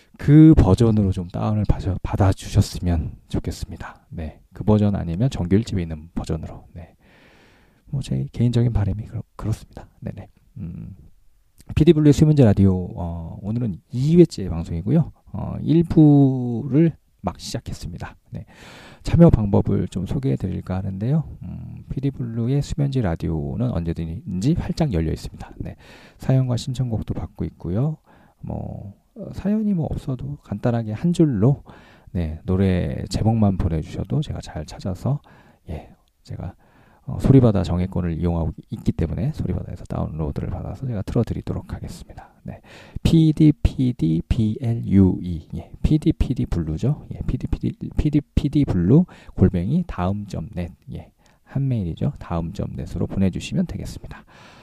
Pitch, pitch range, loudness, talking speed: 105 Hz, 90-130 Hz, -21 LUFS, 310 characters per minute